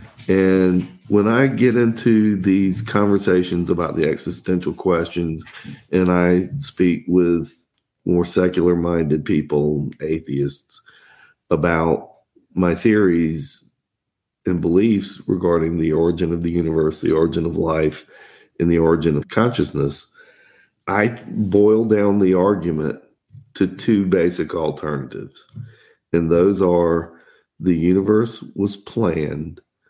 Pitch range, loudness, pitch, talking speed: 80-100 Hz, -19 LUFS, 90 Hz, 110 wpm